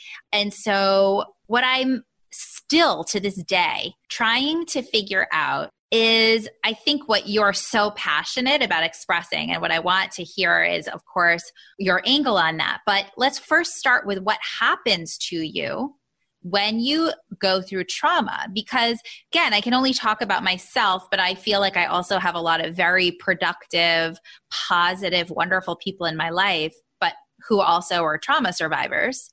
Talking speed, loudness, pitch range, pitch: 165 wpm, -21 LUFS, 180-240 Hz, 200 Hz